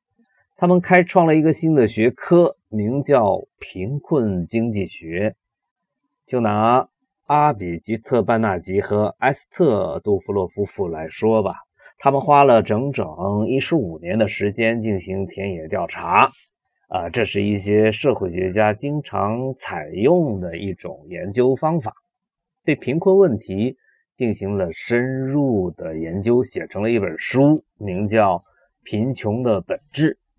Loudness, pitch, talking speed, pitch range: -20 LUFS, 120 Hz, 205 characters per minute, 105-150 Hz